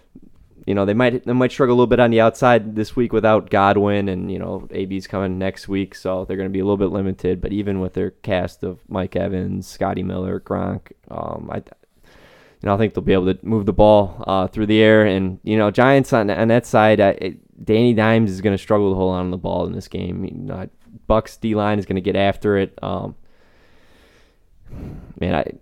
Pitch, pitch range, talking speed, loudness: 100 Hz, 95-110 Hz, 235 wpm, -19 LUFS